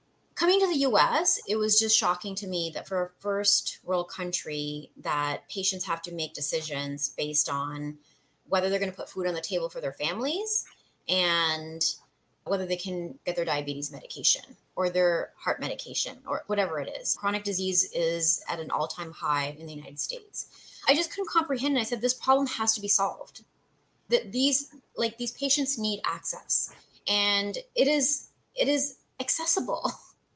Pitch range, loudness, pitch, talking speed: 165-265 Hz, -26 LUFS, 190 Hz, 175 wpm